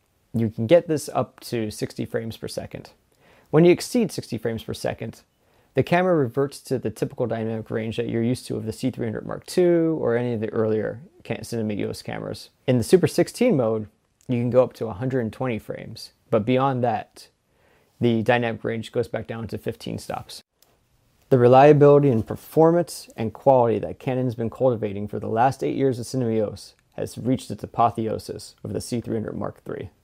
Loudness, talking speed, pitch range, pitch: -23 LUFS, 185 wpm, 110-135 Hz, 120 Hz